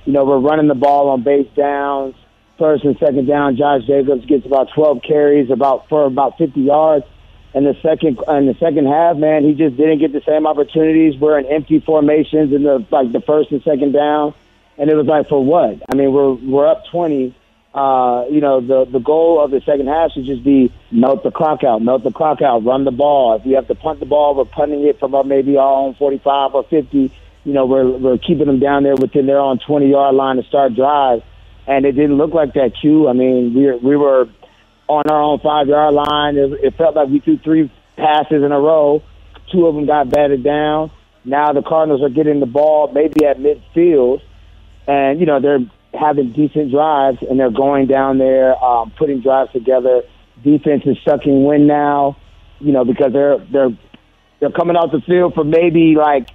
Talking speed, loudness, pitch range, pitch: 215 wpm, -14 LUFS, 135-150 Hz, 145 Hz